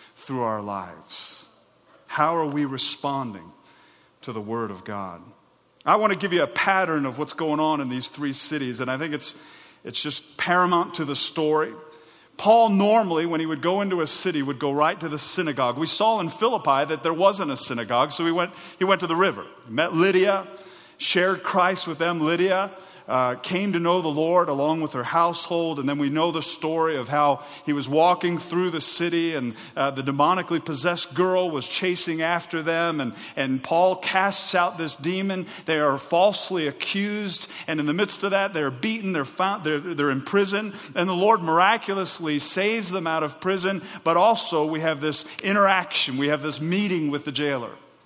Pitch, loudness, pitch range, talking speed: 165 Hz, -23 LUFS, 150-185 Hz, 200 wpm